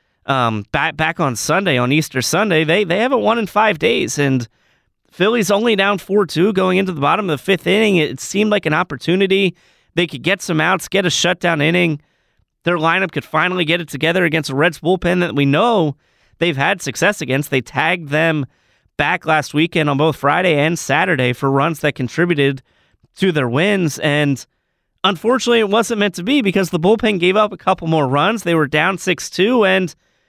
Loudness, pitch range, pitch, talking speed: -16 LUFS, 145-195 Hz, 170 Hz, 205 wpm